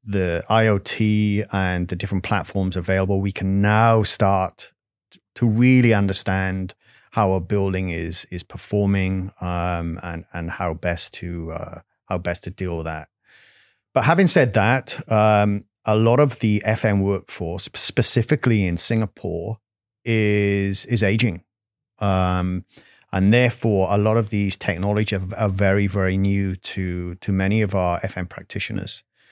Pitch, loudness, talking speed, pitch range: 100 Hz, -20 LUFS, 140 wpm, 90-110 Hz